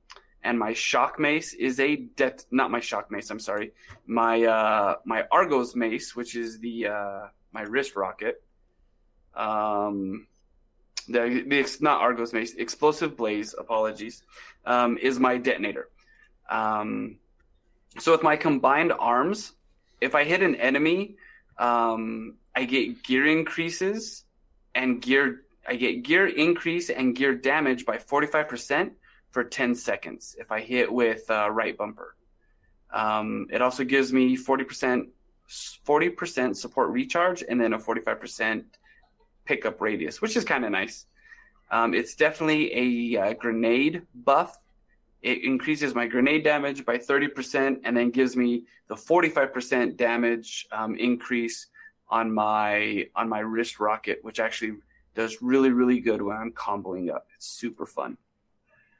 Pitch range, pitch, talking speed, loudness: 115-140 Hz, 120 Hz, 140 wpm, -25 LUFS